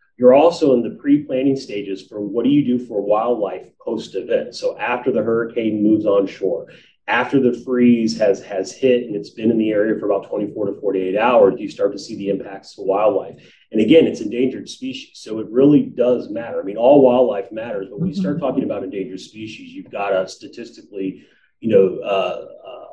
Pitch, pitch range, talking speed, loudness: 110 Hz, 100-130 Hz, 200 wpm, -18 LUFS